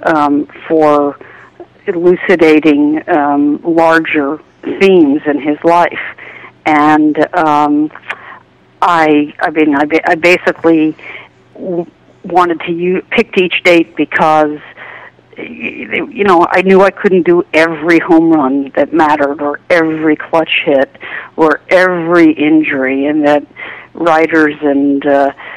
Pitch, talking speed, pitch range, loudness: 160 Hz, 110 wpm, 150-175 Hz, -10 LUFS